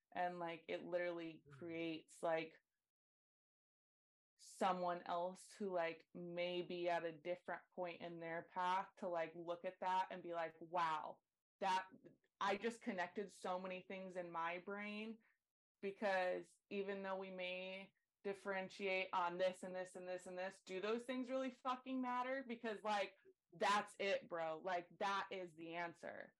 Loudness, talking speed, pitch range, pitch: -46 LUFS, 155 wpm, 175-200 Hz, 185 Hz